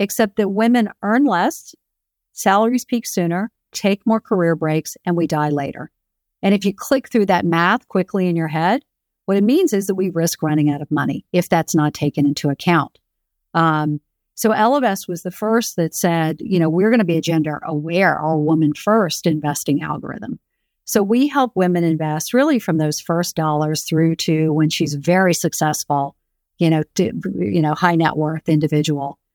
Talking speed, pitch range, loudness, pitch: 185 wpm, 155-200 Hz, -18 LUFS, 170 Hz